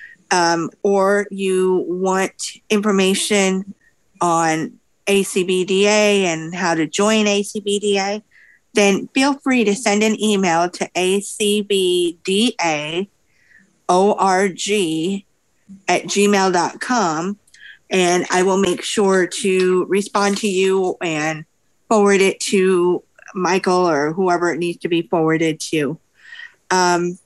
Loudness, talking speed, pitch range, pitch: -17 LUFS, 100 wpm, 175-205 Hz, 190 Hz